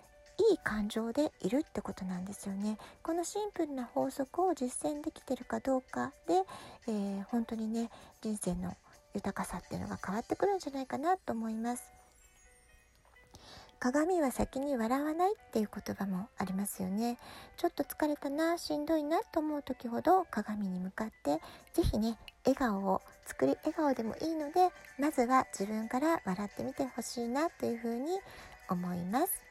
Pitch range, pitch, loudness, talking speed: 215-310 Hz, 255 Hz, -35 LUFS, 330 characters per minute